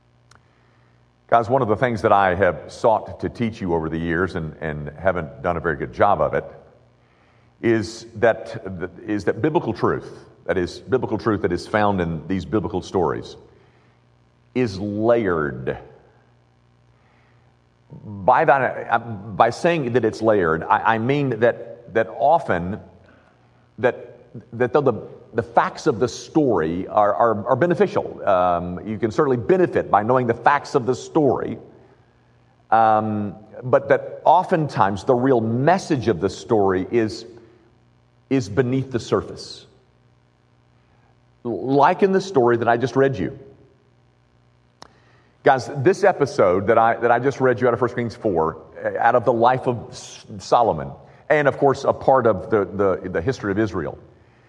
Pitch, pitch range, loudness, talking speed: 110 Hz, 80-125 Hz, -20 LUFS, 155 wpm